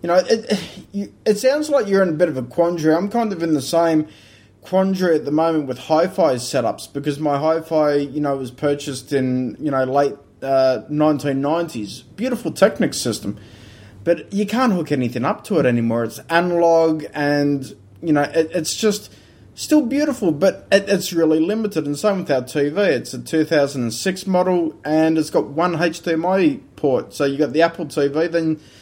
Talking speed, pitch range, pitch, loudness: 190 wpm, 140-180 Hz, 160 Hz, -19 LUFS